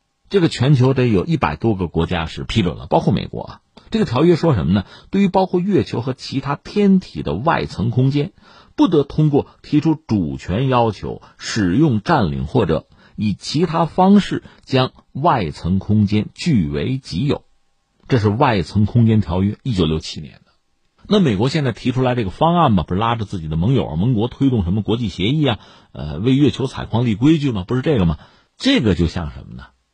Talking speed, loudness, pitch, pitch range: 290 characters per minute, -18 LUFS, 120 Hz, 95-145 Hz